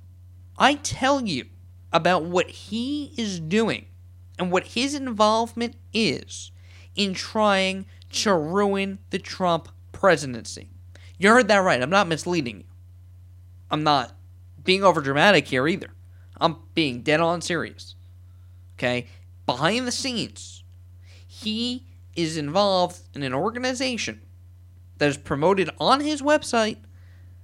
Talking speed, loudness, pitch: 120 wpm, -23 LUFS, 145 Hz